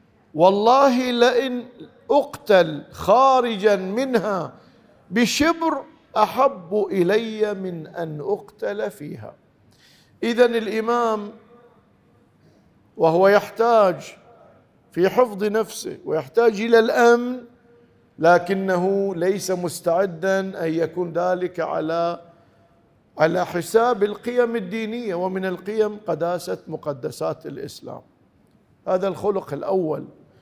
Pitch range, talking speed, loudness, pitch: 180-235 Hz, 80 wpm, -21 LUFS, 205 Hz